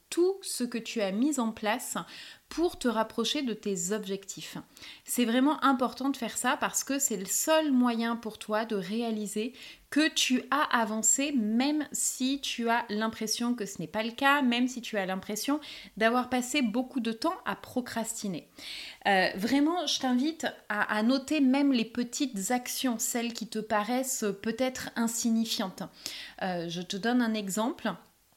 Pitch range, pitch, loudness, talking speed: 220-270 Hz, 235 Hz, -29 LUFS, 170 wpm